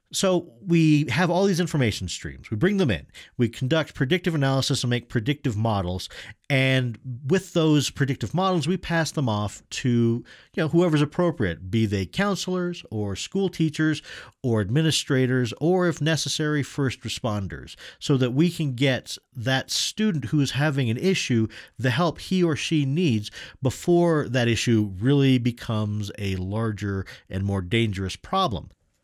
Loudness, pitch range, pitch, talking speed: -24 LUFS, 115-160 Hz, 135 Hz, 155 wpm